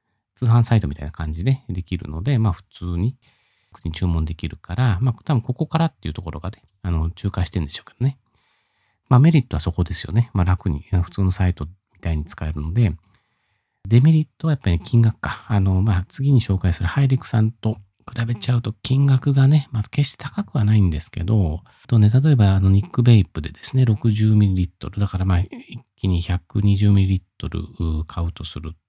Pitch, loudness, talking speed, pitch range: 105 Hz, -20 LUFS, 380 characters per minute, 90-120 Hz